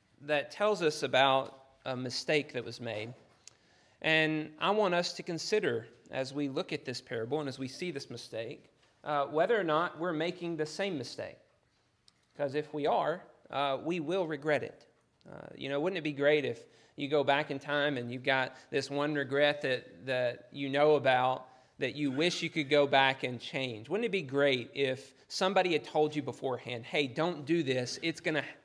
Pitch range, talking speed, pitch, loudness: 130-155 Hz, 200 wpm, 145 Hz, -32 LUFS